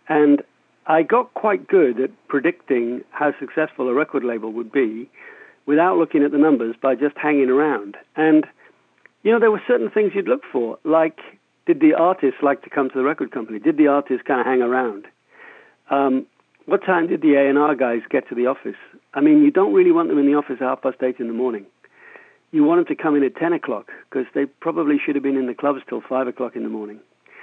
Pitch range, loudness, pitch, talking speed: 130-200 Hz, -19 LUFS, 145 Hz, 225 wpm